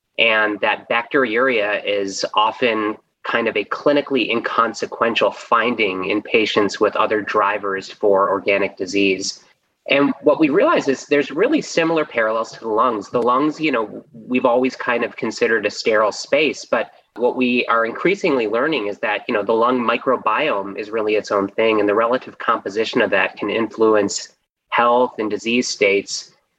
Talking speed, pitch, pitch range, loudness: 165 wpm, 110 Hz, 100-125 Hz, -18 LUFS